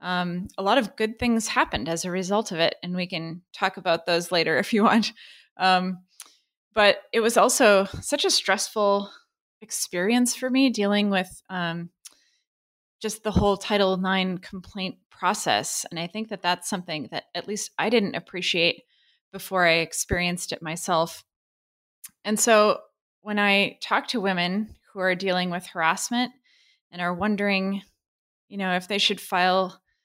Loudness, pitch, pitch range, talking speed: -24 LUFS, 195 Hz, 180-215 Hz, 160 wpm